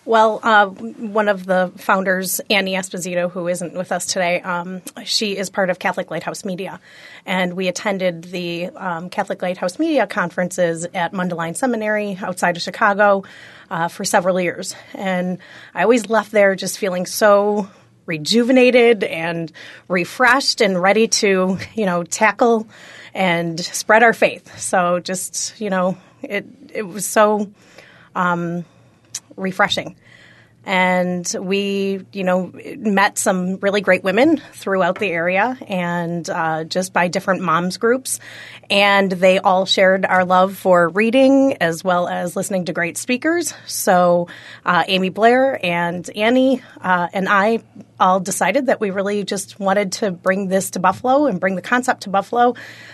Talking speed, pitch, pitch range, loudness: 150 wpm, 190 Hz, 180-215 Hz, -18 LUFS